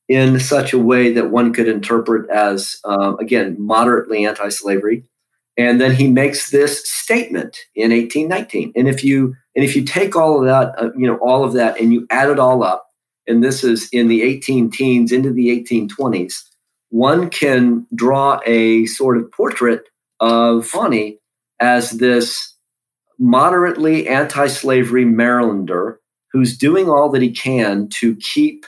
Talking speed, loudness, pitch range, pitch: 155 wpm, -15 LUFS, 115-135 Hz, 125 Hz